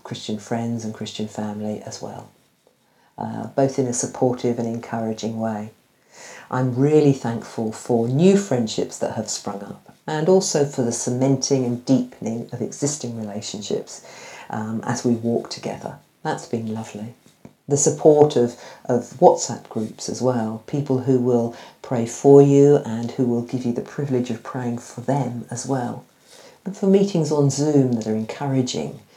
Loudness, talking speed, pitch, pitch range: -21 LUFS, 160 wpm, 120 Hz, 115-135 Hz